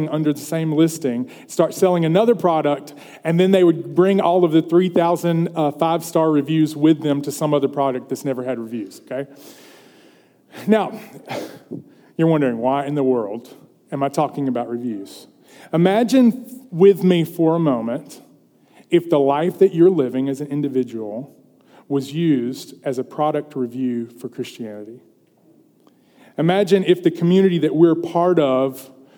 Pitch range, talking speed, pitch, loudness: 135-175 Hz, 155 wpm, 155 Hz, -19 LUFS